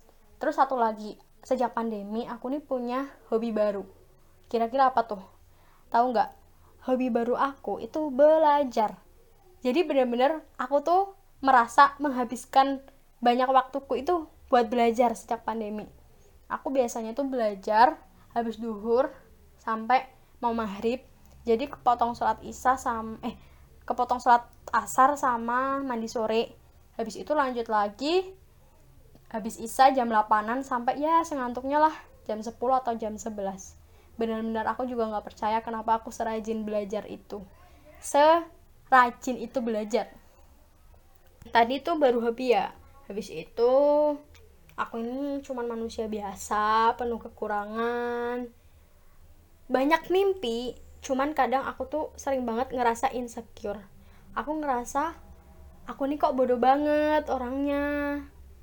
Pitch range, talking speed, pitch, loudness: 225-270 Hz, 120 wpm, 245 Hz, -27 LUFS